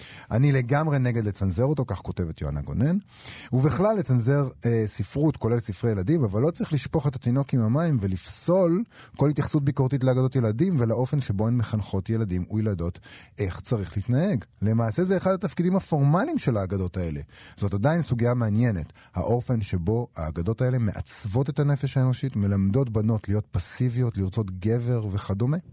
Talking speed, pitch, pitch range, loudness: 155 wpm, 120 Hz, 100-140 Hz, -25 LUFS